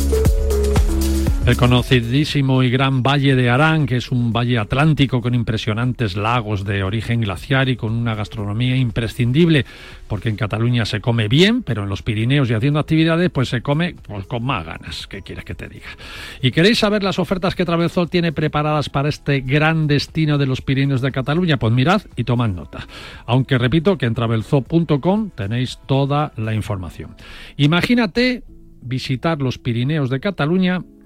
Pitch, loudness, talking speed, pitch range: 130 Hz, -18 LUFS, 165 wpm, 115-150 Hz